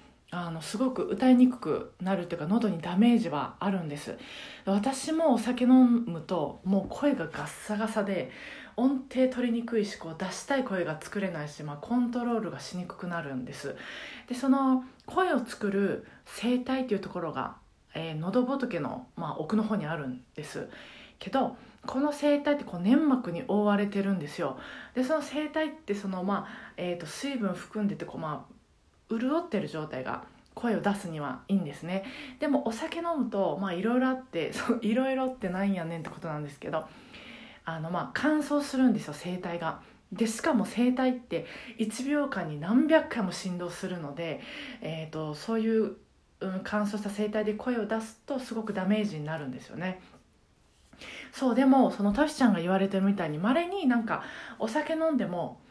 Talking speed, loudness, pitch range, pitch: 350 characters per minute, -30 LUFS, 185-260 Hz, 215 Hz